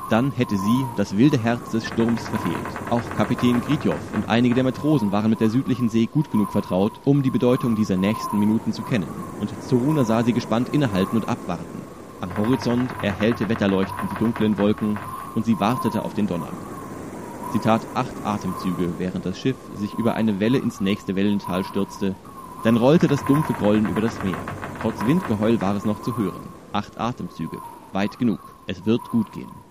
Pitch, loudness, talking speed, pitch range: 110 Hz, -23 LUFS, 185 wpm, 105-120 Hz